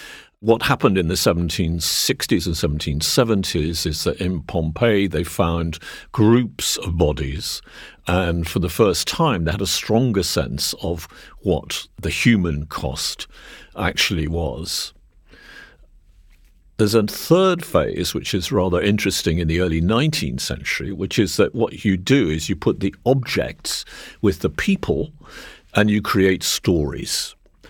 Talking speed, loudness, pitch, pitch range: 140 wpm, -20 LUFS, 90 Hz, 80-105 Hz